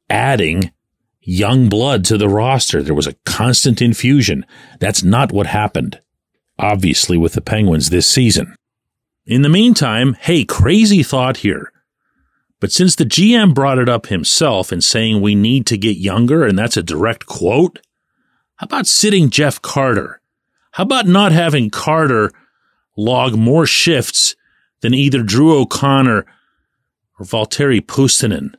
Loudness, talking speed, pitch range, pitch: -13 LUFS, 145 wpm, 105-140 Hz, 120 Hz